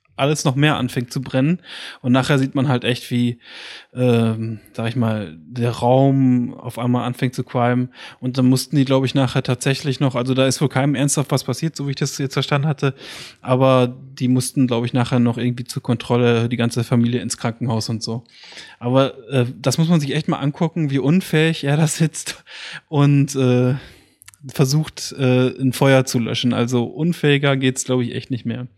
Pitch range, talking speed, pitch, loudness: 120-140 Hz, 200 wpm, 130 Hz, -19 LUFS